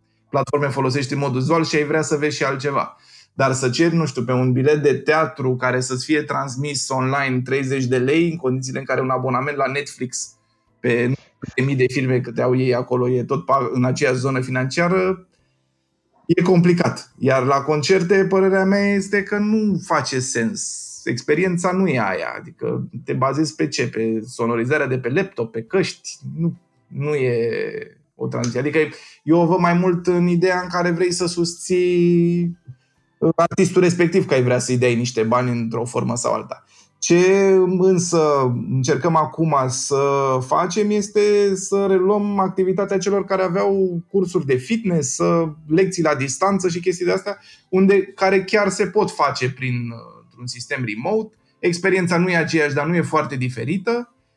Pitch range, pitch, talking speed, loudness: 130-185 Hz, 155 Hz, 170 wpm, -19 LUFS